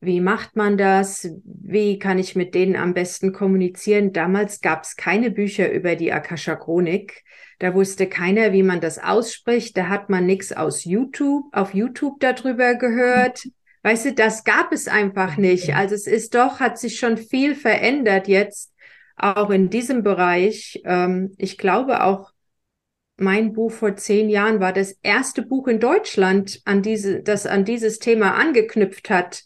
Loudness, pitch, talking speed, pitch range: -19 LUFS, 205 Hz, 165 wpm, 190-230 Hz